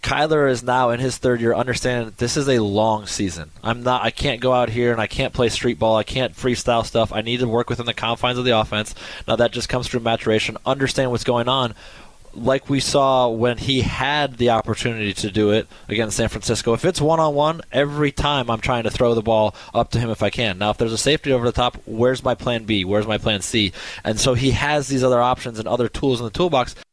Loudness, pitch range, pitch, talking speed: -20 LUFS, 110-130 Hz, 120 Hz, 245 wpm